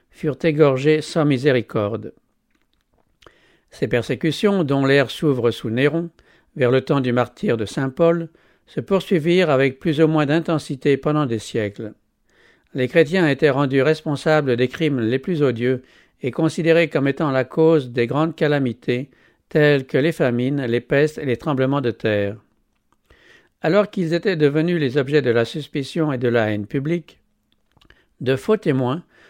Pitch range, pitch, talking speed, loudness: 130-160 Hz, 145 Hz, 155 wpm, -19 LUFS